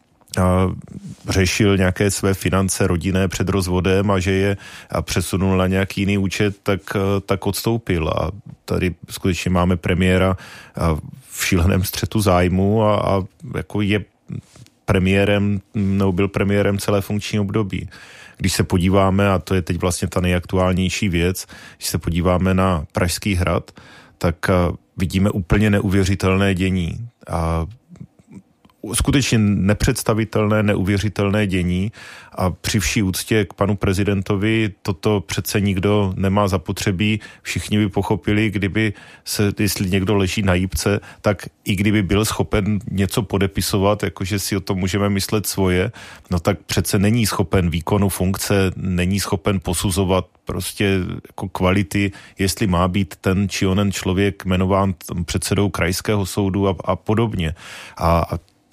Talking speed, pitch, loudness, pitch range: 135 wpm, 100 Hz, -19 LUFS, 95-105 Hz